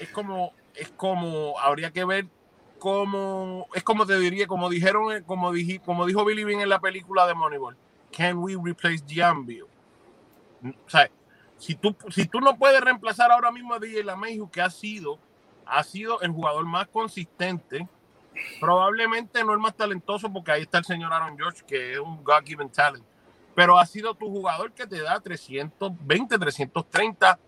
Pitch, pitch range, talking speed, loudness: 185 Hz, 165-210 Hz, 175 wpm, -24 LUFS